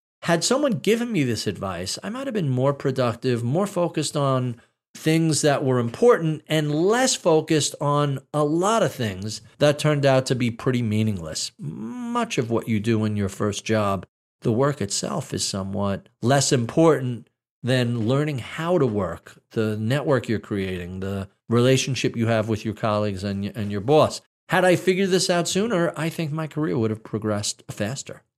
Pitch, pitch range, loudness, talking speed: 130 Hz, 110-155 Hz, -23 LUFS, 175 wpm